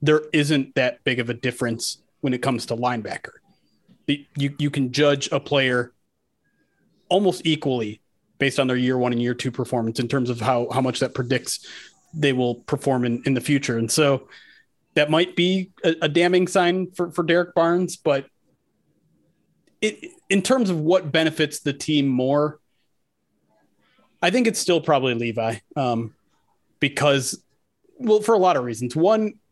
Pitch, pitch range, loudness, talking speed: 145 Hz, 125-175 Hz, -22 LUFS, 170 wpm